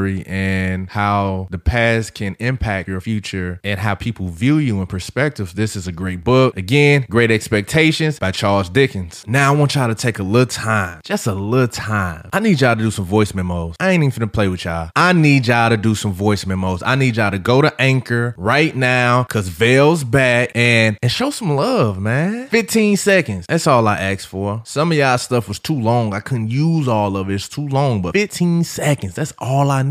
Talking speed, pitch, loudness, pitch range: 225 wpm, 115 Hz, -17 LUFS, 100-140 Hz